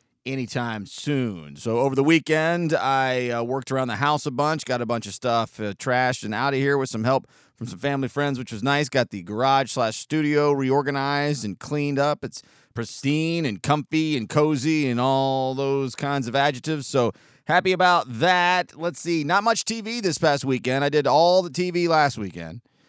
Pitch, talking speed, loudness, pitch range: 140 Hz, 195 wpm, -23 LUFS, 125-155 Hz